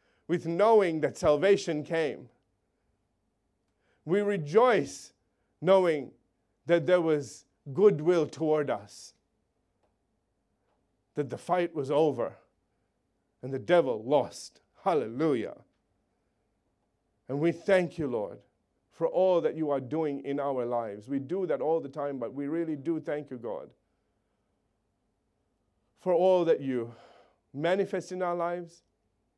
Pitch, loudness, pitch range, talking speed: 155 Hz, -28 LUFS, 140-175 Hz, 120 wpm